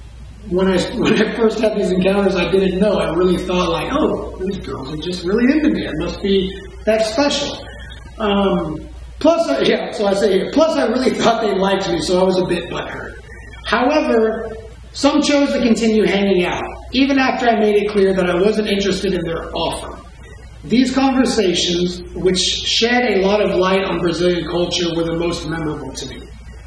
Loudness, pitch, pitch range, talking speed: -17 LUFS, 195 Hz, 175-220 Hz, 190 wpm